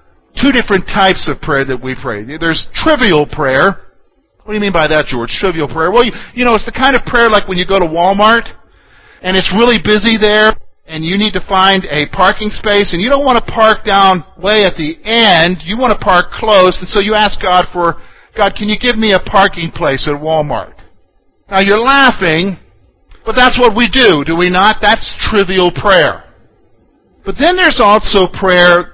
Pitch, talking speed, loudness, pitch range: 195 Hz, 205 wpm, -10 LUFS, 170-220 Hz